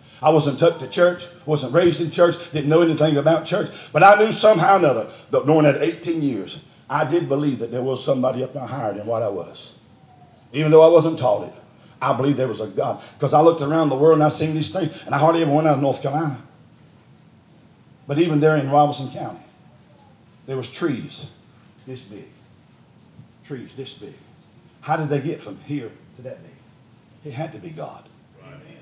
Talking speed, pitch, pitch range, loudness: 205 wpm, 150 Hz, 135-160 Hz, -19 LUFS